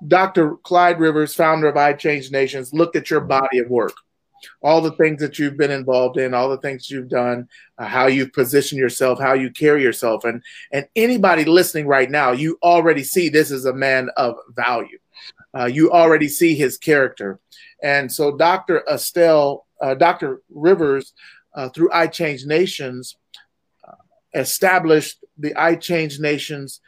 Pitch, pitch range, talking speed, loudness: 150 Hz, 135-165 Hz, 165 wpm, -17 LUFS